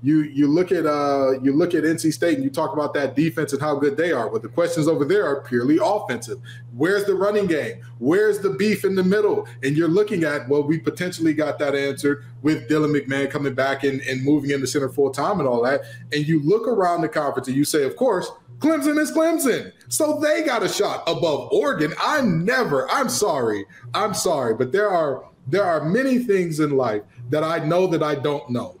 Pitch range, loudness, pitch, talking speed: 140-175 Hz, -21 LUFS, 150 Hz, 225 wpm